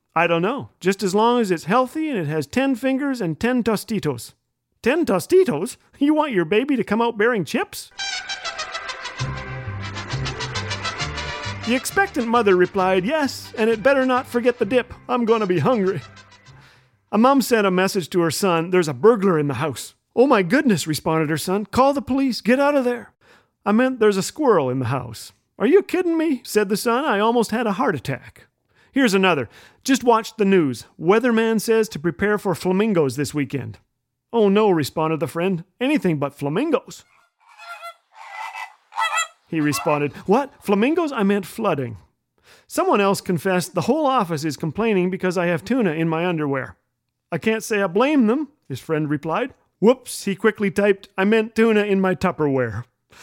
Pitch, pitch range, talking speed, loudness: 200 Hz, 160-245 Hz, 175 wpm, -20 LUFS